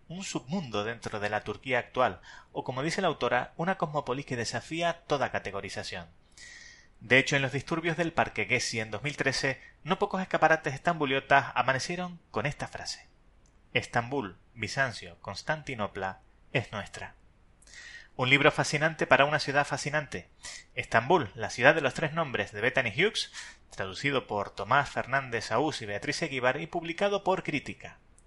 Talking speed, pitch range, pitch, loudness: 150 wpm, 110-160 Hz, 135 Hz, -29 LUFS